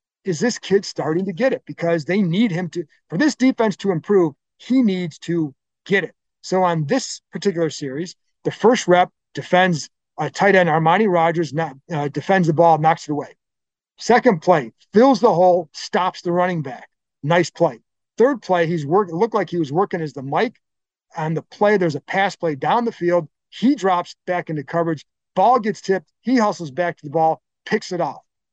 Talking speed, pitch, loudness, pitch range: 200 wpm, 175 Hz, -19 LUFS, 160-205 Hz